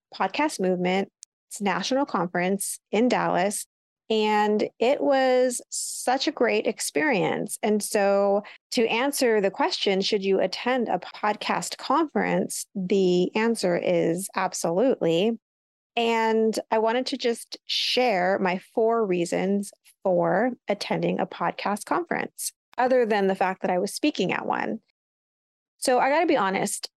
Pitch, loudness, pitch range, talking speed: 215 Hz, -24 LUFS, 190-245 Hz, 130 wpm